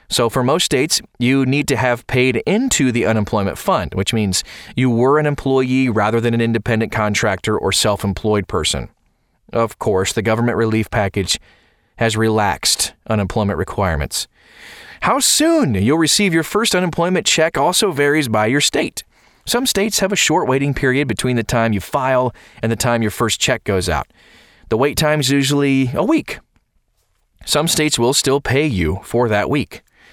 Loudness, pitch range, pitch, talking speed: -16 LUFS, 110-145 Hz, 120 Hz, 175 wpm